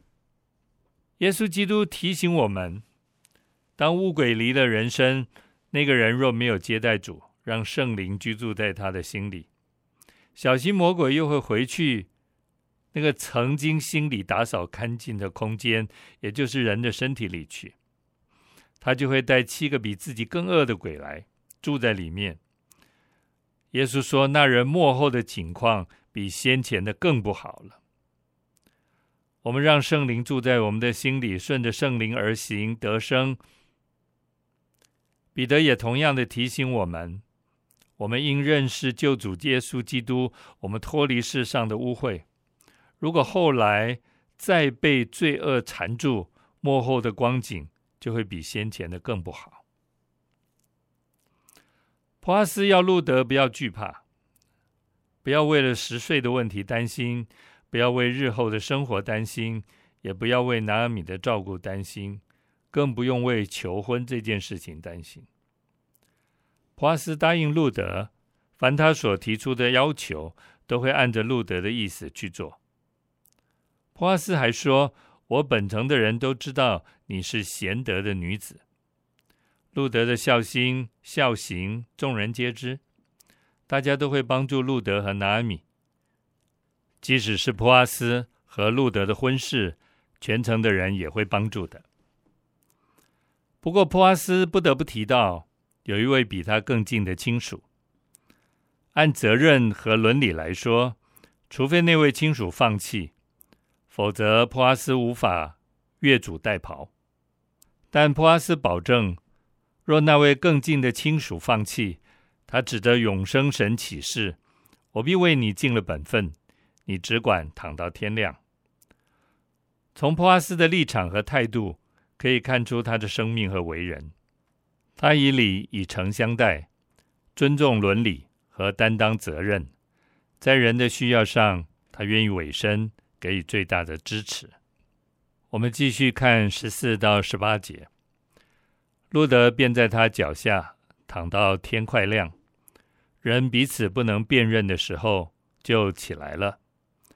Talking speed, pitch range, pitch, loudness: 205 characters per minute, 100-135 Hz, 115 Hz, -23 LUFS